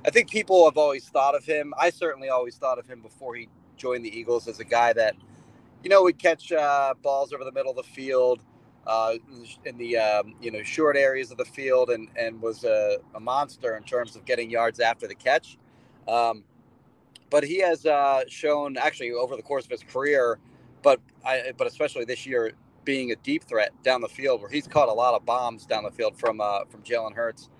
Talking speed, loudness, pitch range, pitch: 220 wpm, -25 LUFS, 115-170 Hz, 135 Hz